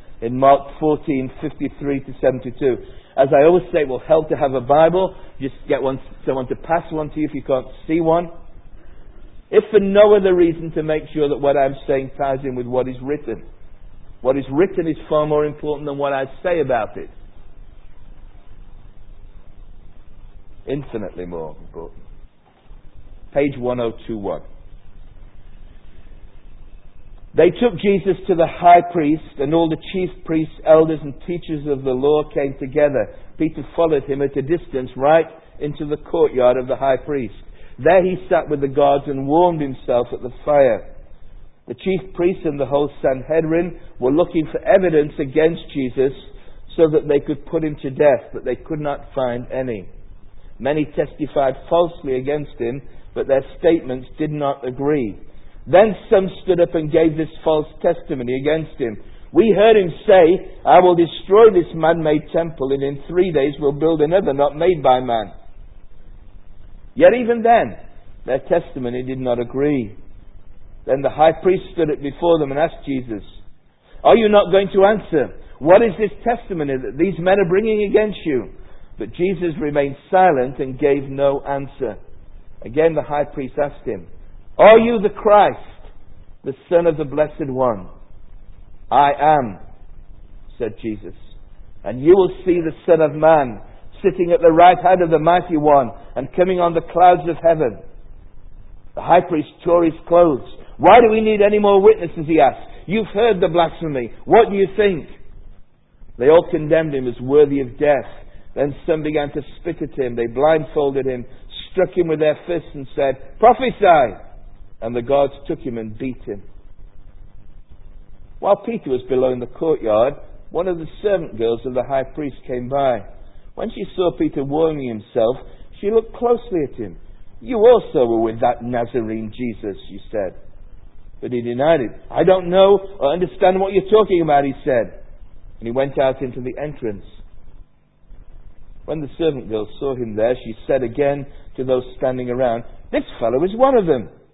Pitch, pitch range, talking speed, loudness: 140 Hz, 115-170 Hz, 170 wpm, -17 LUFS